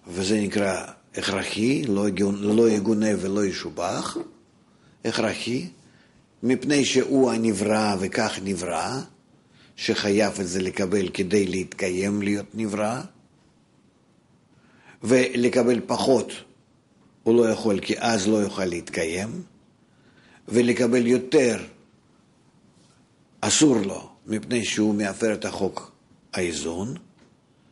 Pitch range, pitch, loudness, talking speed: 100-120 Hz, 105 Hz, -24 LUFS, 90 wpm